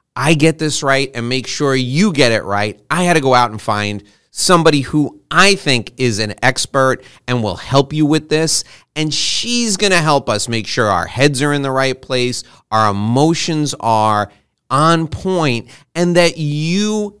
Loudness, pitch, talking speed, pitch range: -15 LUFS, 140 Hz, 190 wpm, 120-160 Hz